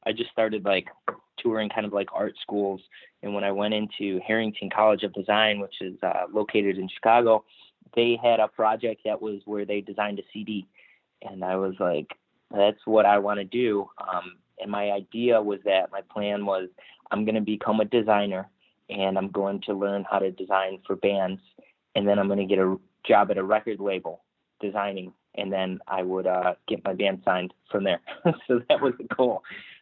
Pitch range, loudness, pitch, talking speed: 95-105 Hz, -26 LUFS, 100 Hz, 200 wpm